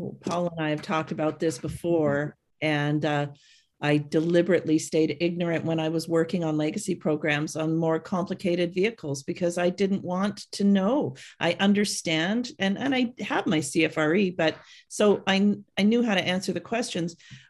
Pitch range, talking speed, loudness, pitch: 155-195 Hz, 170 wpm, -26 LUFS, 170 Hz